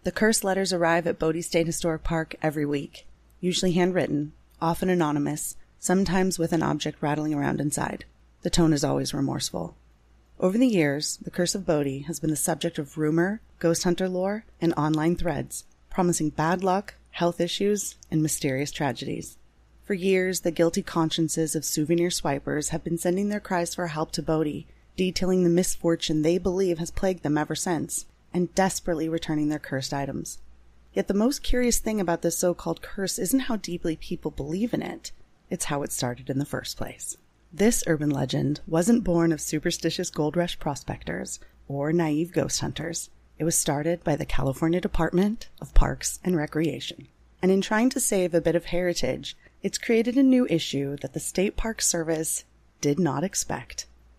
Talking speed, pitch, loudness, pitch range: 175 wpm, 170 Hz, -26 LUFS, 150-185 Hz